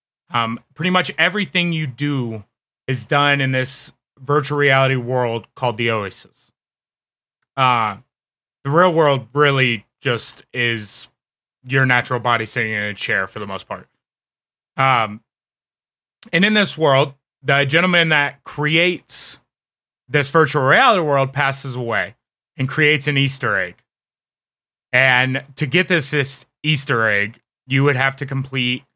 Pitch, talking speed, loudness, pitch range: 135 Hz, 135 wpm, -18 LUFS, 125-150 Hz